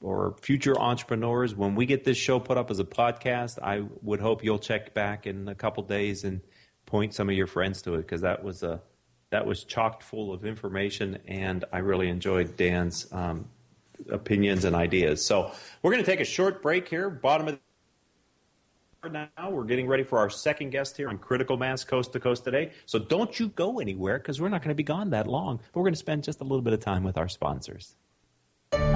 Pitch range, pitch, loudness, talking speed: 95-135 Hz, 110 Hz, -28 LUFS, 220 wpm